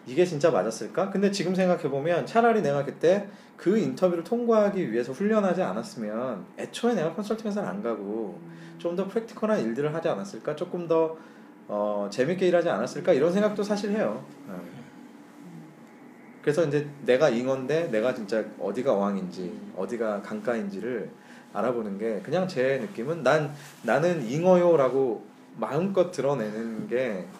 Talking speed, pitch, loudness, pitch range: 335 characters per minute, 170 Hz, -27 LUFS, 130-195 Hz